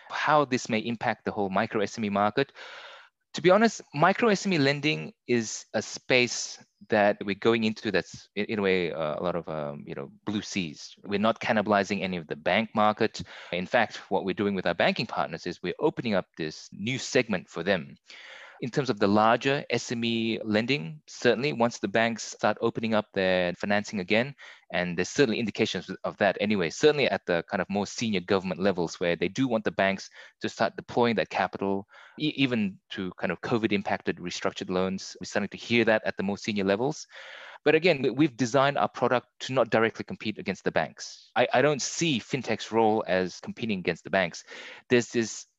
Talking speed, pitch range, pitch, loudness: 195 wpm, 95-130 Hz, 110 Hz, -27 LUFS